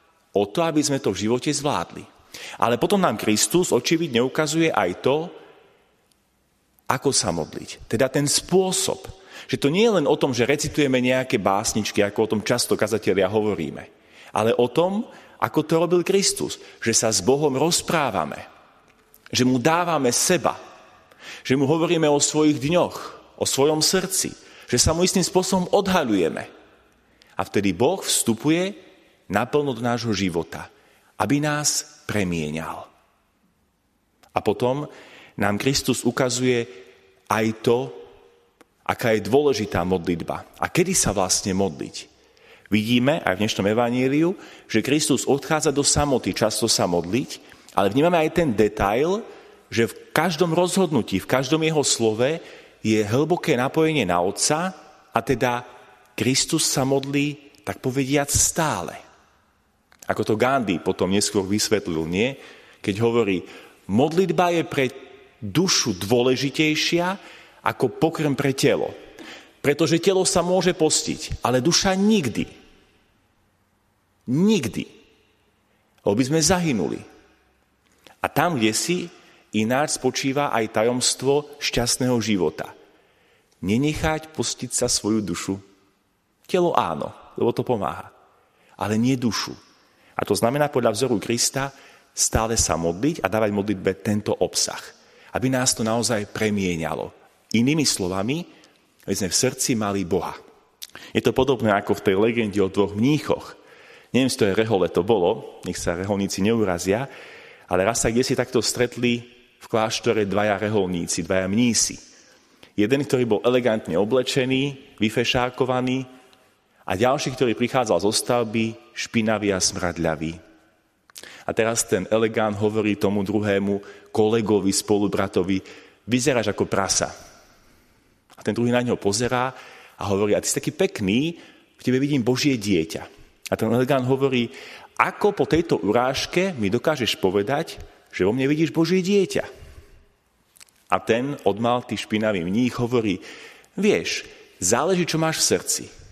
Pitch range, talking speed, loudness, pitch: 105-150 Hz, 135 wpm, -22 LUFS, 125 Hz